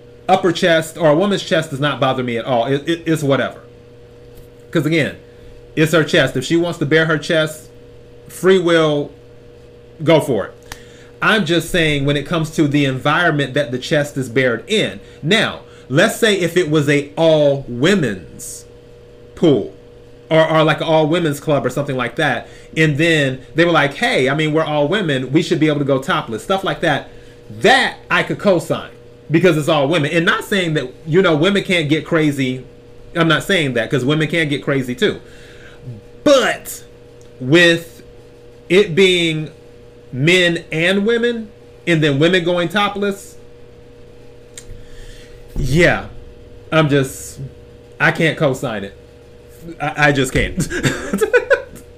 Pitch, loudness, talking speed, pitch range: 145 Hz, -16 LUFS, 160 wpm, 120-165 Hz